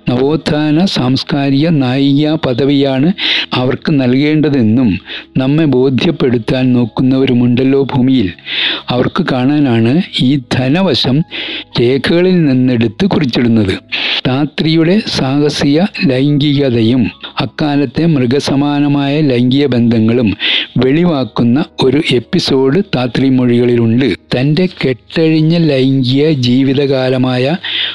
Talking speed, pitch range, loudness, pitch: 75 wpm, 130-150 Hz, -11 LUFS, 135 Hz